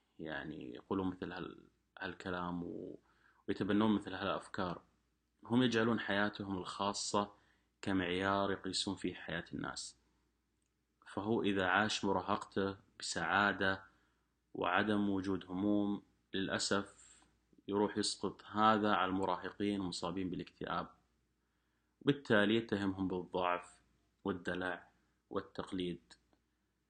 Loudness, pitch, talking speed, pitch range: -37 LUFS, 95 Hz, 85 wpm, 90-100 Hz